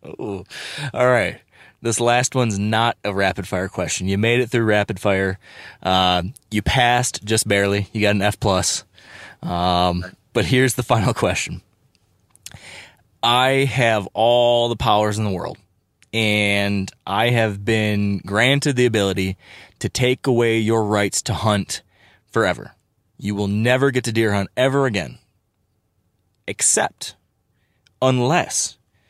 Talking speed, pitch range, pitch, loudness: 140 wpm, 100-120 Hz, 105 Hz, -19 LUFS